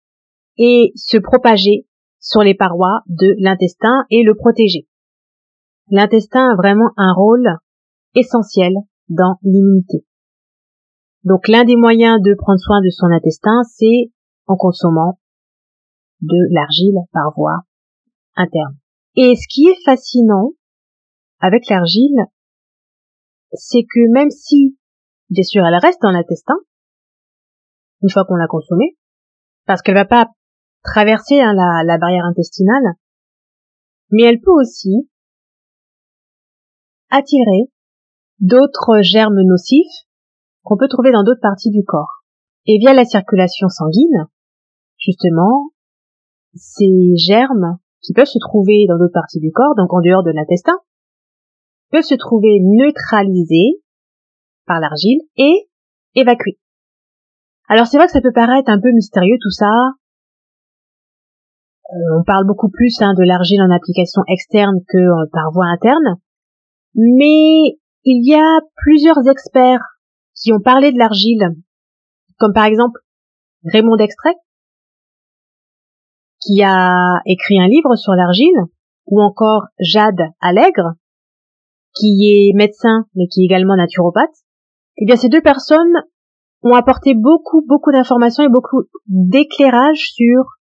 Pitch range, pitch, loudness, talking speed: 185-255 Hz, 215 Hz, -11 LUFS, 125 wpm